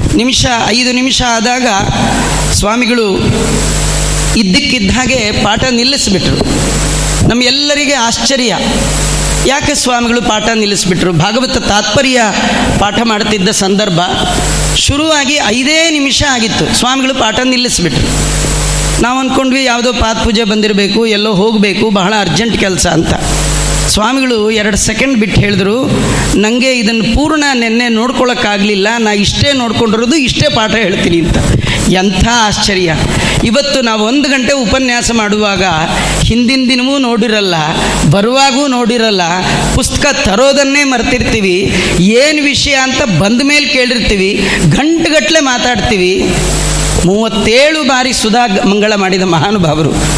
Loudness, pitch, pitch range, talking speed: -9 LUFS, 230 Hz, 200-255 Hz, 100 wpm